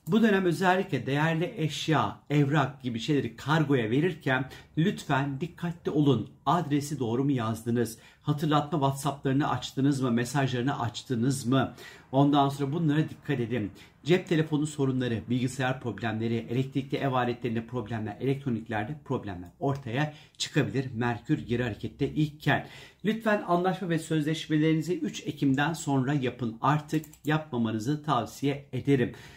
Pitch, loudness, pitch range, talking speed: 140 Hz, -29 LUFS, 125-155 Hz, 120 wpm